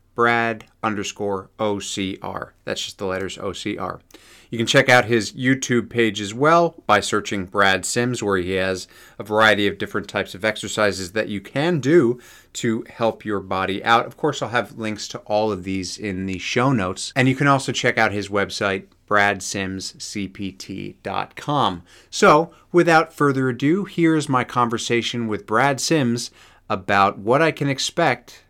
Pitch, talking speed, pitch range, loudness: 110 Hz, 160 wpm, 100-125 Hz, -20 LUFS